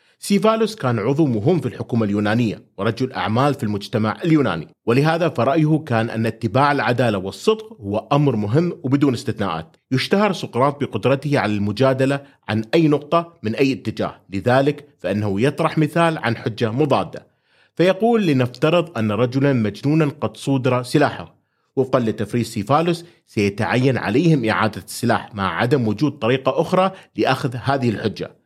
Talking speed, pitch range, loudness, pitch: 135 wpm, 110-150 Hz, -20 LUFS, 130 Hz